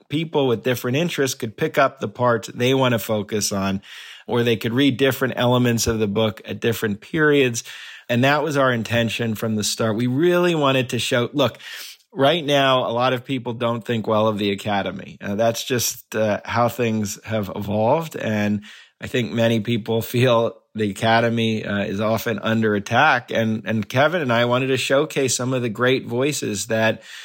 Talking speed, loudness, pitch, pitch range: 190 wpm, -20 LUFS, 115 Hz, 110-130 Hz